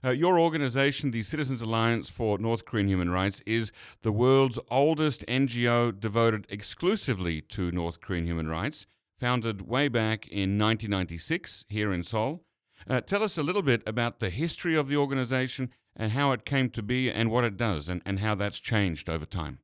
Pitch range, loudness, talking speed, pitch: 100-130 Hz, -28 LUFS, 185 wpm, 115 Hz